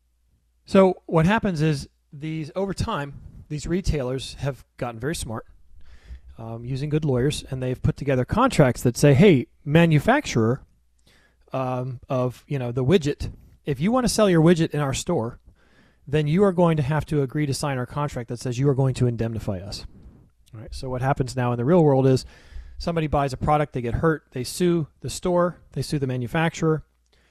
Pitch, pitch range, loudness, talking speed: 140 Hz, 120-160 Hz, -23 LUFS, 195 wpm